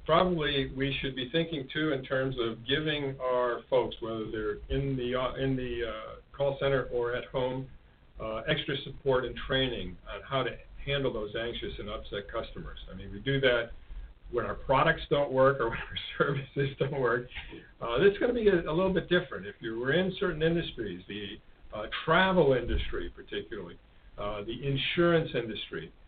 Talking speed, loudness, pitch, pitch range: 185 wpm, -30 LUFS, 135 Hz, 120-150 Hz